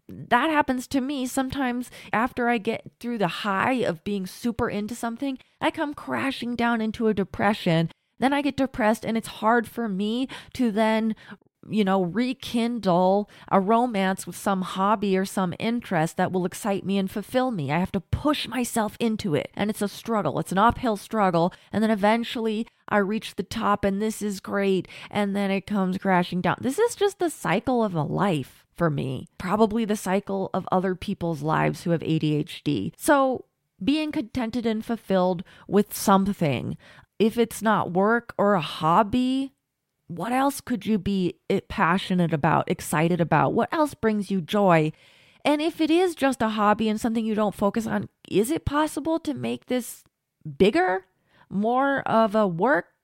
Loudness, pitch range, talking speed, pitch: -25 LUFS, 185-235 Hz, 175 wpm, 210 Hz